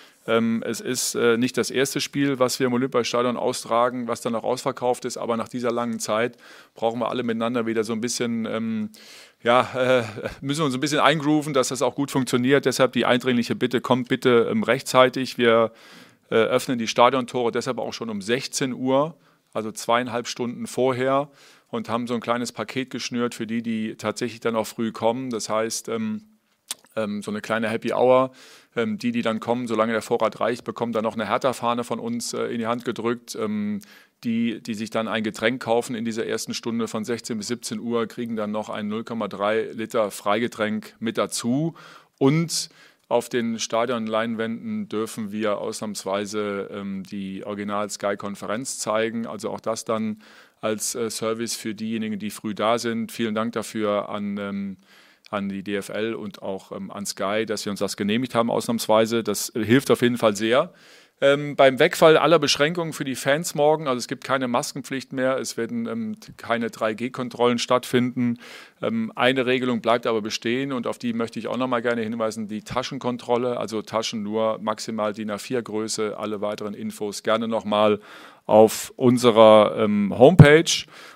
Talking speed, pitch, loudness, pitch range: 170 wpm, 115 Hz, -23 LUFS, 110-130 Hz